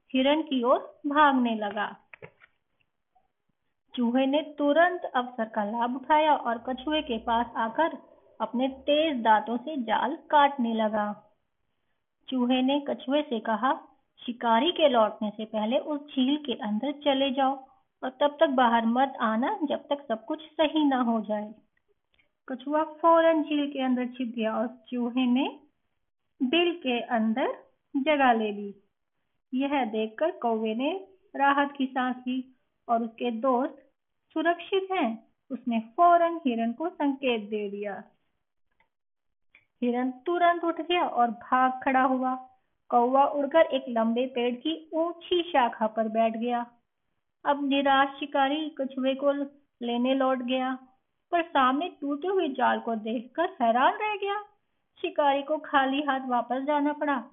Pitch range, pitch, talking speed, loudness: 240-300 Hz, 265 Hz, 140 wpm, -27 LUFS